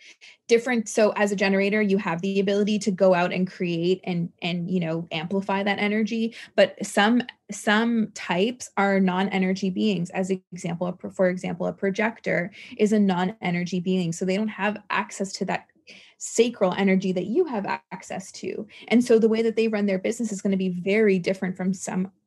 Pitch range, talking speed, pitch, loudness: 185-215 Hz, 190 wpm, 195 Hz, -24 LUFS